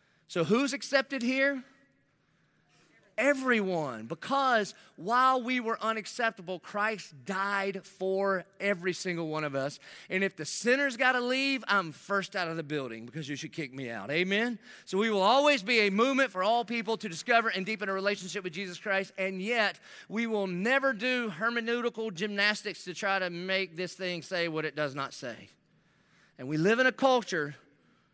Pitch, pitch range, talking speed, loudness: 200 Hz, 180-235 Hz, 175 wpm, -30 LUFS